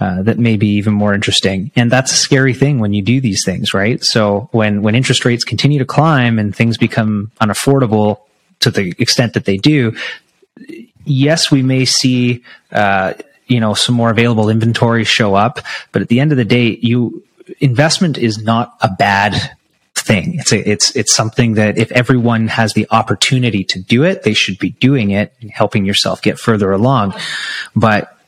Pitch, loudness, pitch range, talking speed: 115 Hz, -13 LUFS, 105-130 Hz, 190 wpm